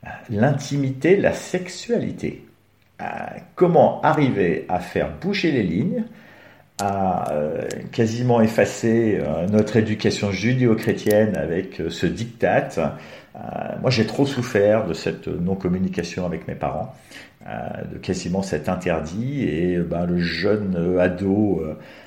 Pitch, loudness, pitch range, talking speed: 105 Hz, -22 LUFS, 95-125 Hz, 105 wpm